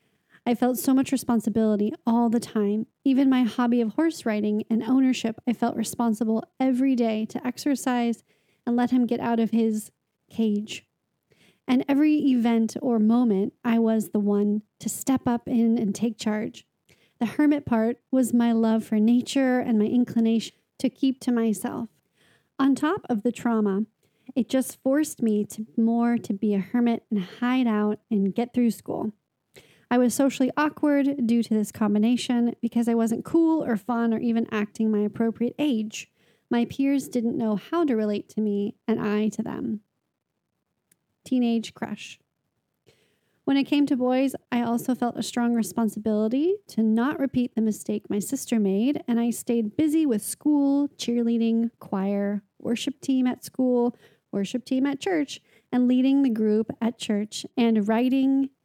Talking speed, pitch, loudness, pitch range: 165 wpm, 235 Hz, -25 LUFS, 220-255 Hz